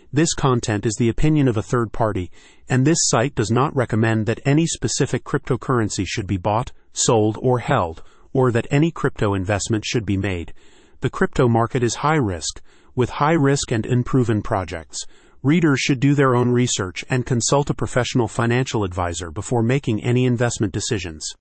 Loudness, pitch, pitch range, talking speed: -20 LUFS, 120 Hz, 105-135 Hz, 175 wpm